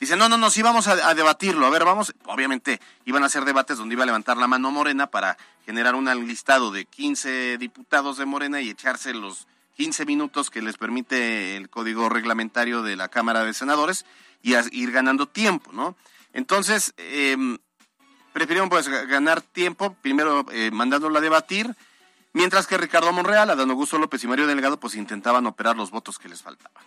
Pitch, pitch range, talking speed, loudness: 140 Hz, 120-180 Hz, 185 wpm, -22 LUFS